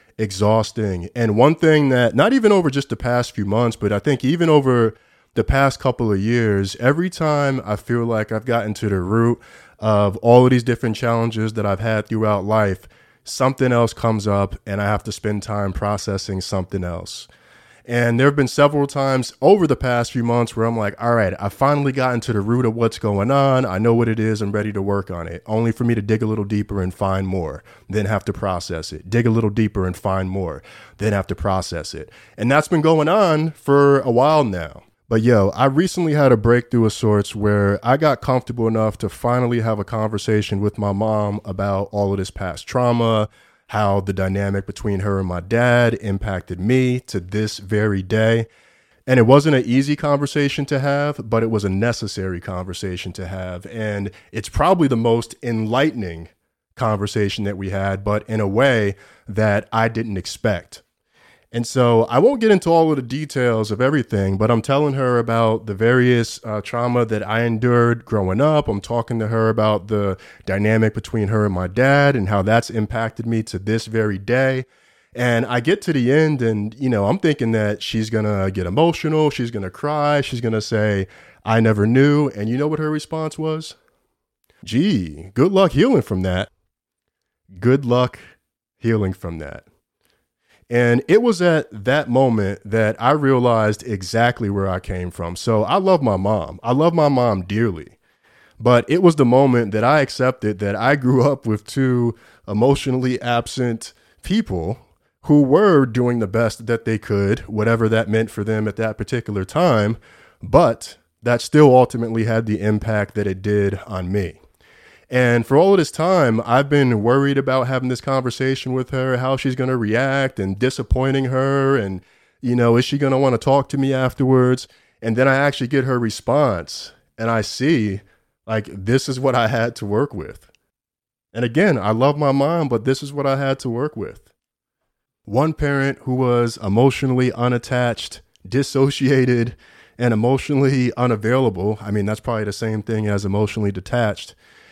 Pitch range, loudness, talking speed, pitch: 105-130 Hz, -19 LUFS, 190 wpm, 115 Hz